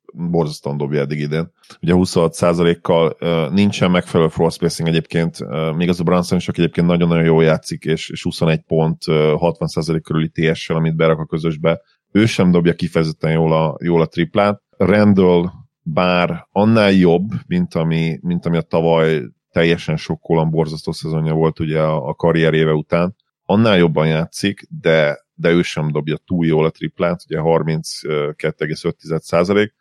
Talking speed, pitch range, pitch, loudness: 150 wpm, 80-85 Hz, 80 Hz, -17 LUFS